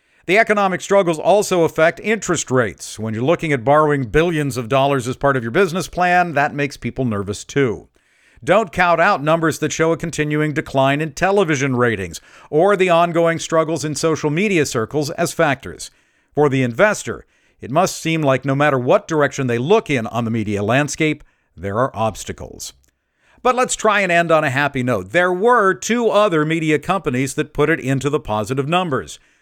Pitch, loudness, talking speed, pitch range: 150 Hz, -17 LUFS, 185 wpm, 130-170 Hz